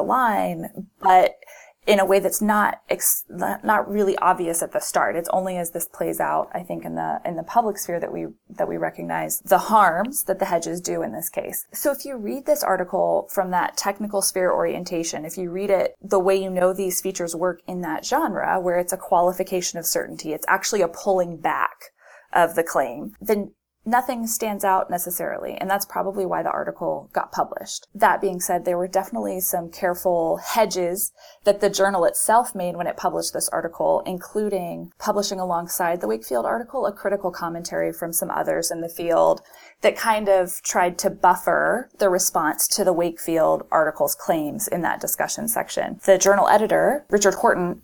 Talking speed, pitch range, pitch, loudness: 190 wpm, 175-200 Hz, 185 Hz, -22 LUFS